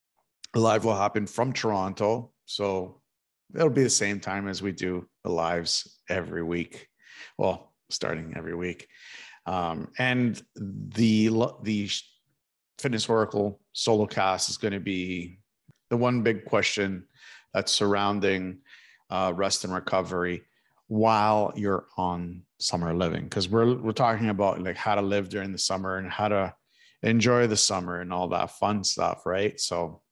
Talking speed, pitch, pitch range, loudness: 145 wpm, 100 Hz, 90-110 Hz, -27 LUFS